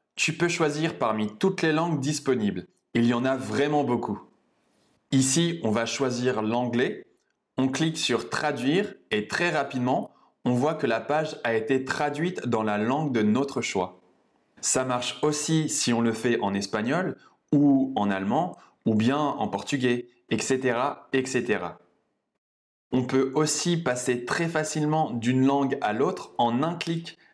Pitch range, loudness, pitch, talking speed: 120-150 Hz, -26 LUFS, 130 Hz, 155 wpm